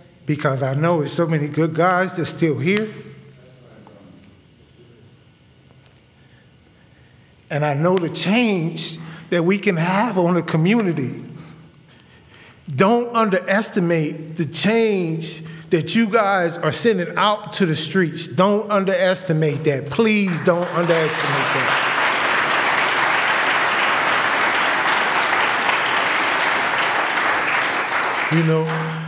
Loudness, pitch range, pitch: -18 LUFS, 160-195 Hz, 170 Hz